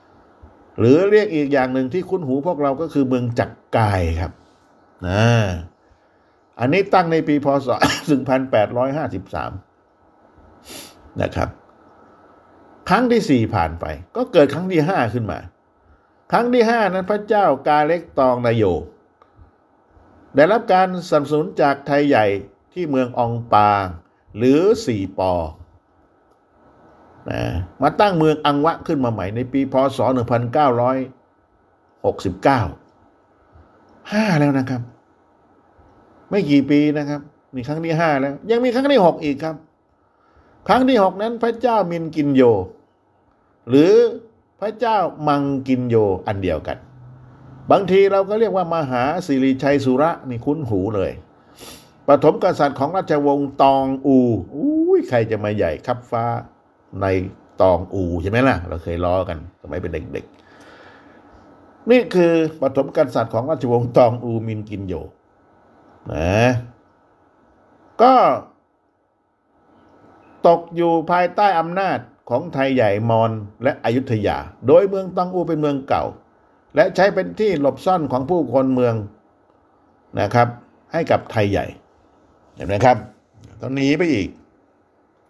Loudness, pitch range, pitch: -18 LUFS, 115-165 Hz, 135 Hz